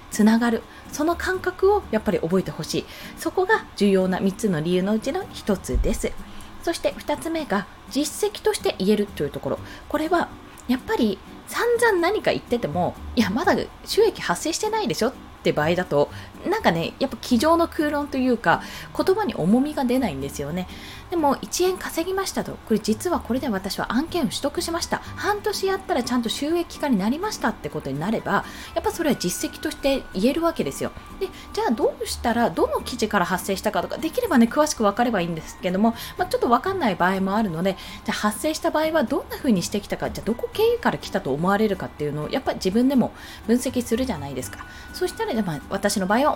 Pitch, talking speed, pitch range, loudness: 245 Hz, 430 characters per minute, 200-335 Hz, -23 LUFS